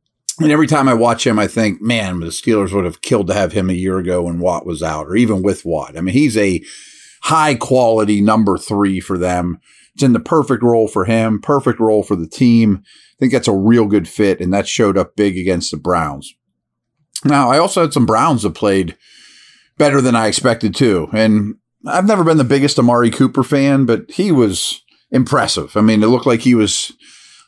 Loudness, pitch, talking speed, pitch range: -14 LUFS, 110 Hz, 215 wpm, 95-130 Hz